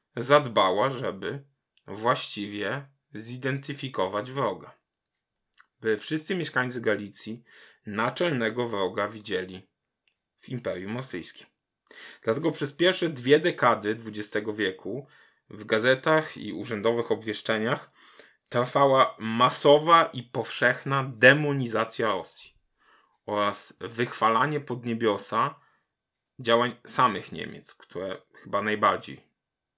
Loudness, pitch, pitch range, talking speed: -26 LUFS, 125 Hz, 110-140 Hz, 85 wpm